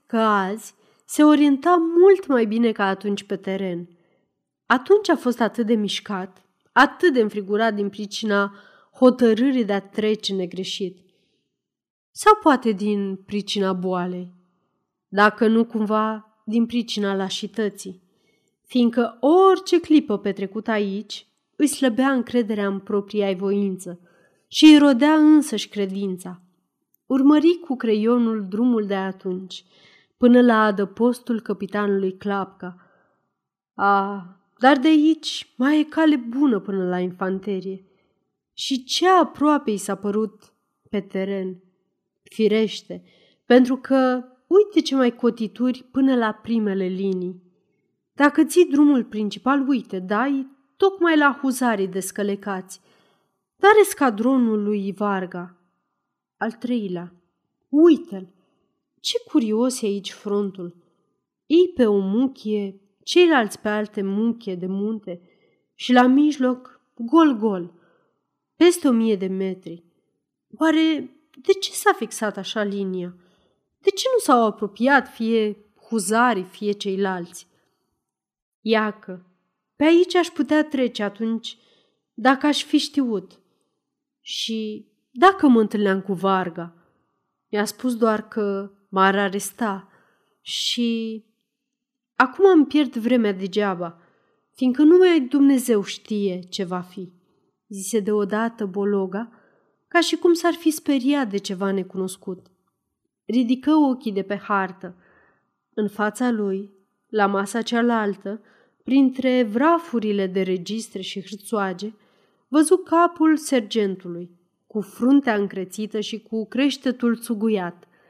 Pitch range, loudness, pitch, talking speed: 195-260 Hz, -20 LUFS, 215 Hz, 115 wpm